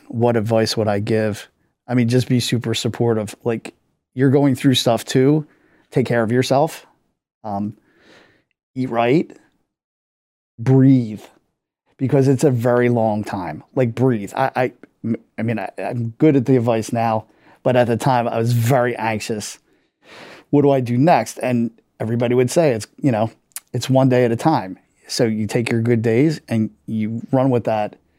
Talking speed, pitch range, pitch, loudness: 170 wpm, 115-130 Hz, 120 Hz, -19 LUFS